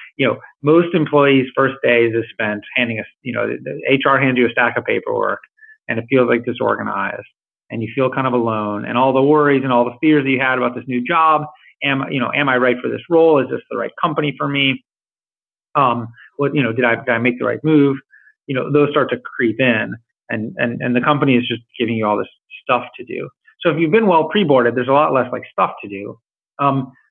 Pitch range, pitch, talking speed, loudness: 120-150 Hz, 135 Hz, 250 wpm, -17 LUFS